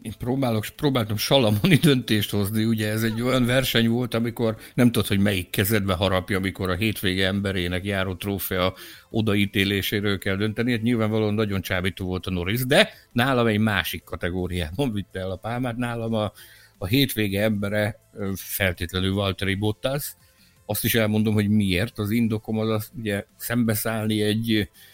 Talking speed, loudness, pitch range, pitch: 155 wpm, -23 LUFS, 95-115 Hz, 105 Hz